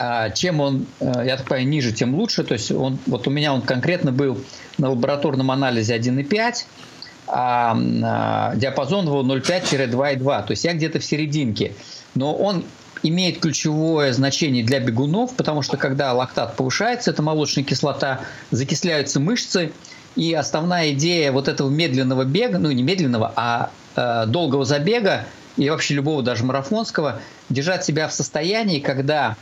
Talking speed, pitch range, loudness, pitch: 150 wpm, 130-160 Hz, -20 LUFS, 140 Hz